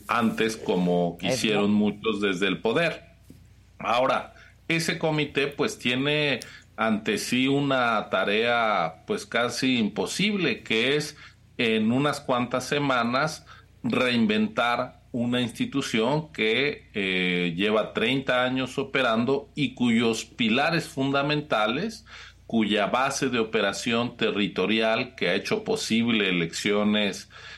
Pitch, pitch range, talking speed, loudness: 130 Hz, 110-150 Hz, 105 wpm, -25 LUFS